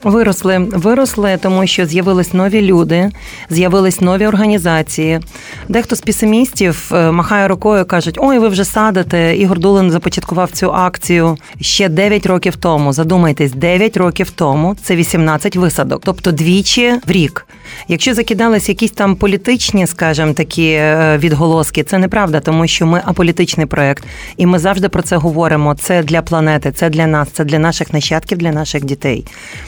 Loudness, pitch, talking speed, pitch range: -12 LUFS, 180 Hz, 150 wpm, 160-195 Hz